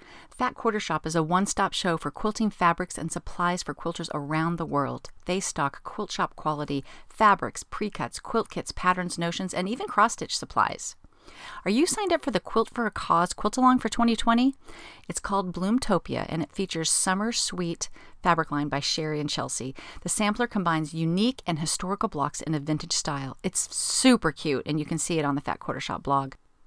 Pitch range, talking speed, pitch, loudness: 155-210 Hz, 195 wpm, 175 Hz, -27 LUFS